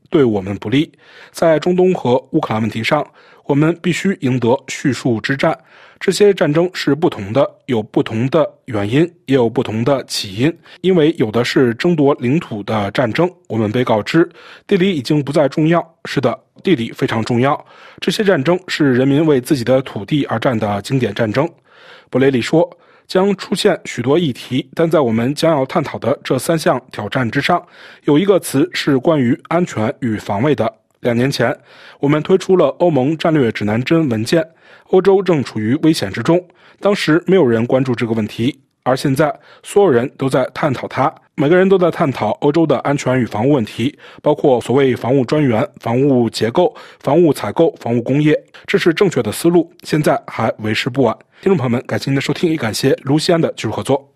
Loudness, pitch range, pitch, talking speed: -16 LUFS, 120-170 Hz, 140 Hz, 290 characters per minute